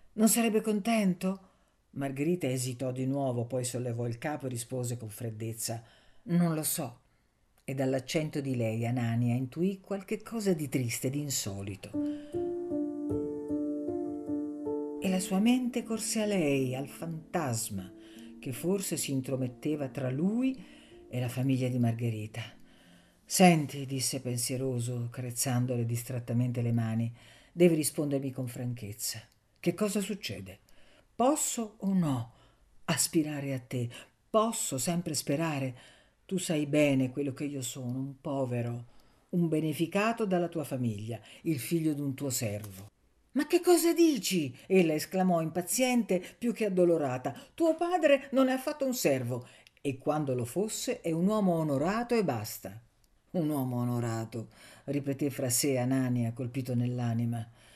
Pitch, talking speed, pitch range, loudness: 140 Hz, 135 wpm, 120-185 Hz, -31 LUFS